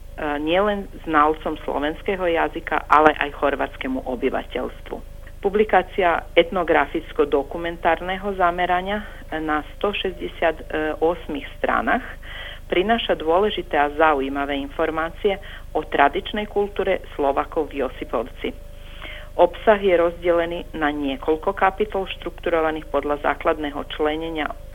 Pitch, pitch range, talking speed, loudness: 165 Hz, 150-185 Hz, 85 wpm, -22 LUFS